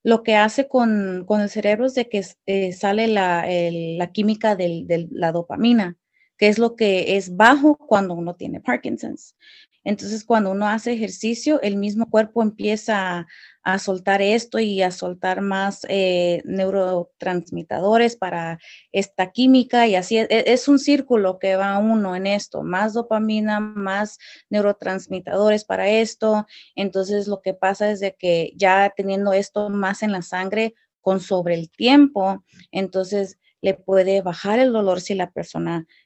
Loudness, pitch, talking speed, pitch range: -20 LUFS, 200 Hz, 160 wpm, 185-220 Hz